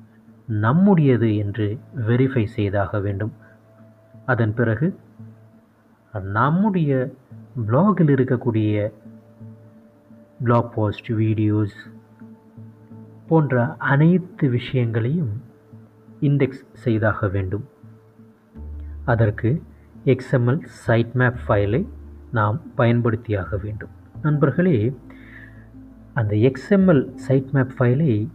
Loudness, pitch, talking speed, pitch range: -21 LUFS, 115 Hz, 70 wpm, 110-130 Hz